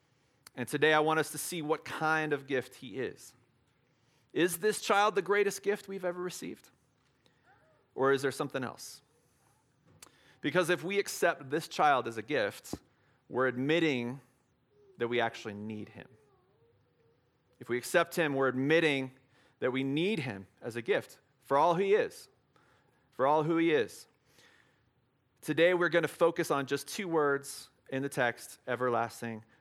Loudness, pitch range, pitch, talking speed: -31 LUFS, 125-165 Hz, 140 Hz, 160 wpm